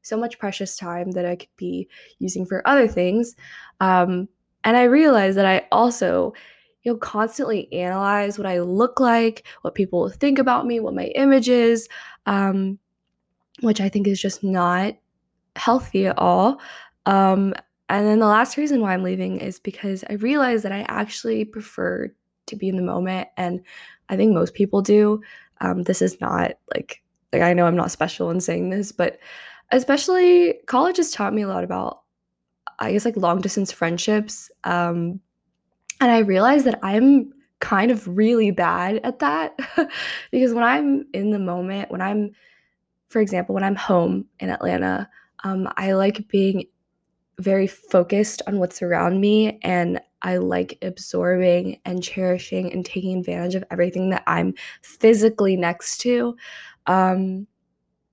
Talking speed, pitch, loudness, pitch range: 160 wpm, 200 Hz, -21 LUFS, 180-230 Hz